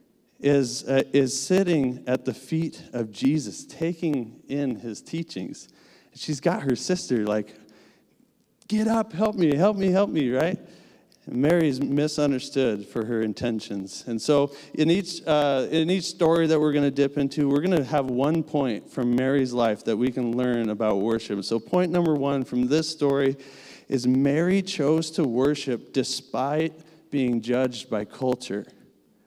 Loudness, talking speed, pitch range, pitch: -25 LUFS, 160 wpm, 125-160 Hz, 140 Hz